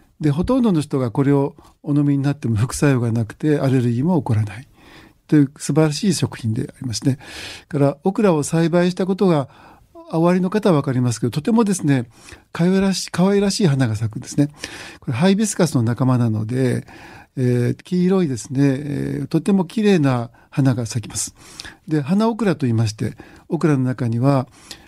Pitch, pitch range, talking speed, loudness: 145 Hz, 125-175 Hz, 370 characters per minute, -19 LUFS